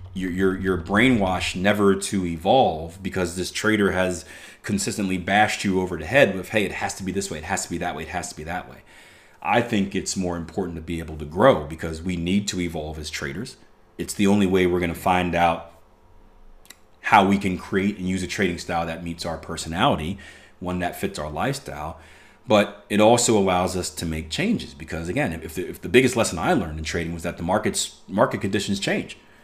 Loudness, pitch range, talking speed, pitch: -23 LUFS, 85-95 Hz, 220 wpm, 90 Hz